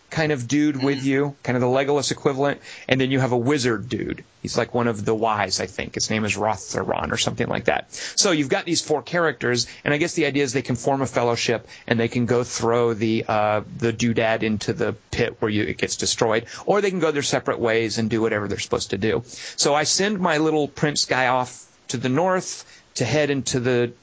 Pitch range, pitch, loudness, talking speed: 115-145 Hz, 130 Hz, -22 LUFS, 240 wpm